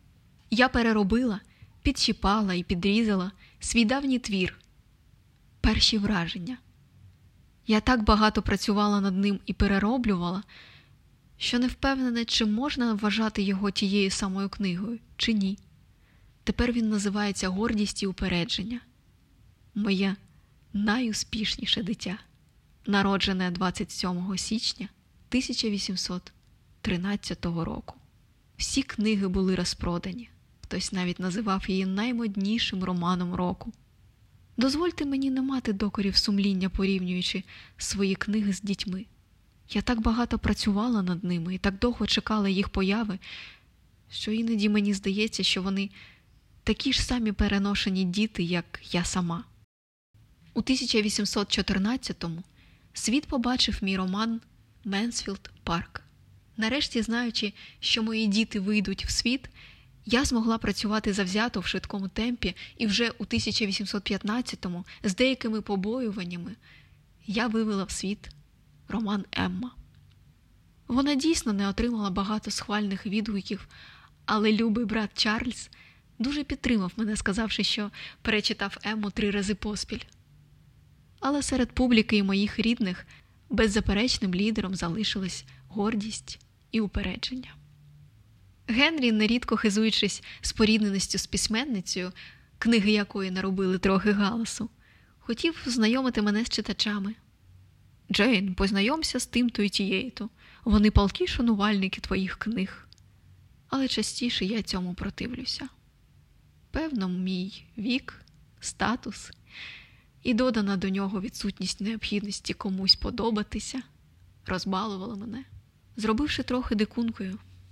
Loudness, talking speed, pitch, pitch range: -27 LUFS, 110 wpm, 210 Hz, 195-230 Hz